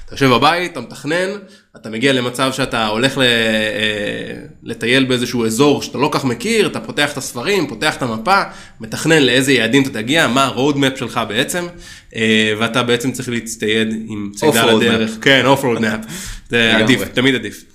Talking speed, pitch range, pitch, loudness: 155 wpm, 110-135 Hz, 125 Hz, -15 LUFS